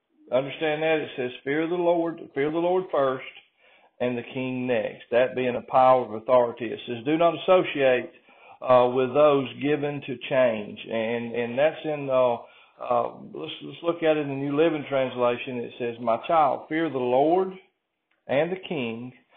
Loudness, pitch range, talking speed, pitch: -25 LUFS, 125-155 Hz, 180 wpm, 135 Hz